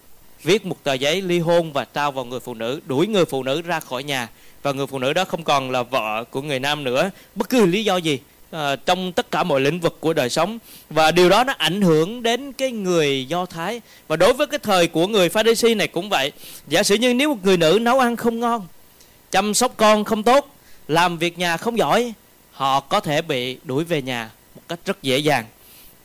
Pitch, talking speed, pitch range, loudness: 170 Hz, 240 wpm, 140-210 Hz, -20 LUFS